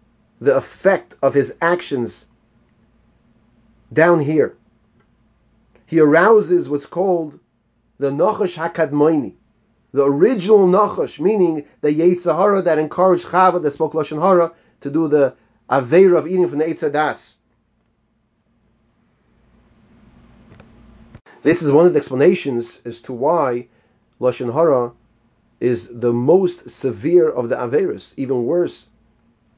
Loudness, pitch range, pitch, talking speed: -17 LUFS, 115-175 Hz, 150 Hz, 115 wpm